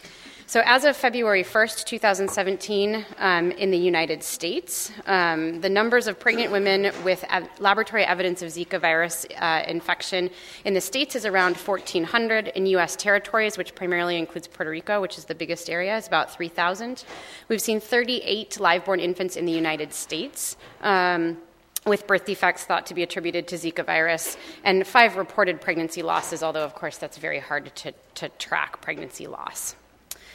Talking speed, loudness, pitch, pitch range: 170 wpm, -23 LUFS, 185 Hz, 170-205 Hz